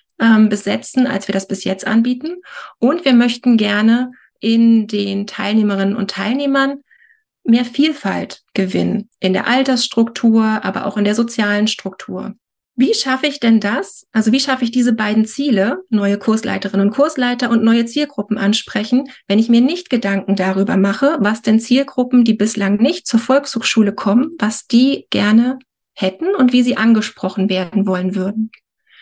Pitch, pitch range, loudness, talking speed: 225 Hz, 205-255 Hz, -15 LUFS, 155 wpm